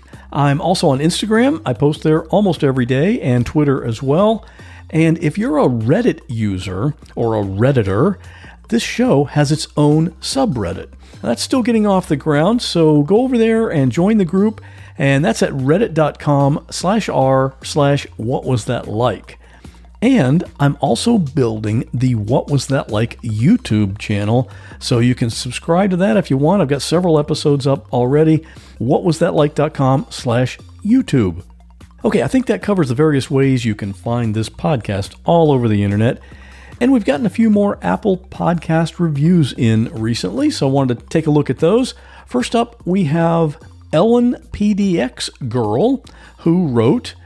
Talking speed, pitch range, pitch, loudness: 160 wpm, 120-175 Hz, 145 Hz, -16 LUFS